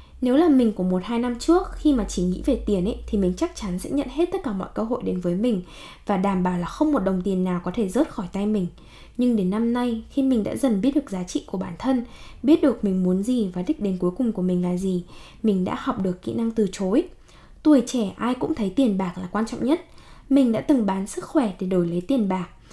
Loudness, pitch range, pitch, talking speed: -23 LUFS, 185-260 Hz, 220 Hz, 275 wpm